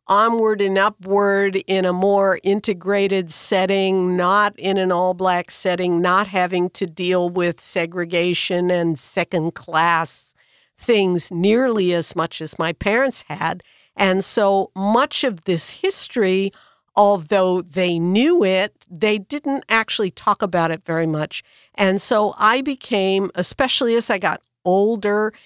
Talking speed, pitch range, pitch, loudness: 135 wpm, 180-210 Hz, 190 Hz, -19 LUFS